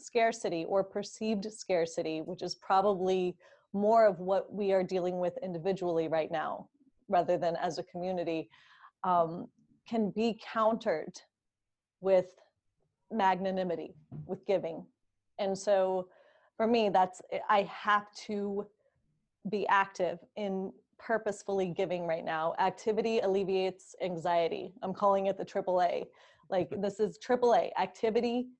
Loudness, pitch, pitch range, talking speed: -32 LUFS, 195 Hz, 180-215 Hz, 120 wpm